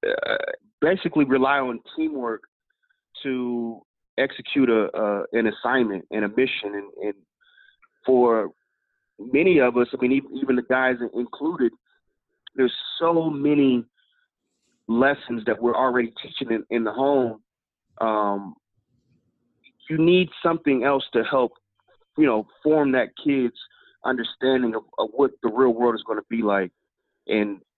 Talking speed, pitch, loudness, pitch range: 135 wpm, 130 Hz, -23 LUFS, 115-170 Hz